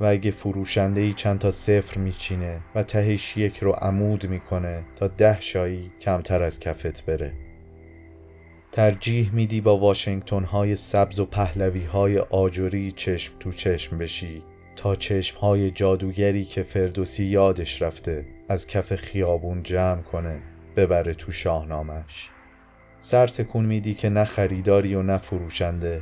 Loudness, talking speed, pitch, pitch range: -24 LUFS, 135 wpm, 95 Hz, 85-100 Hz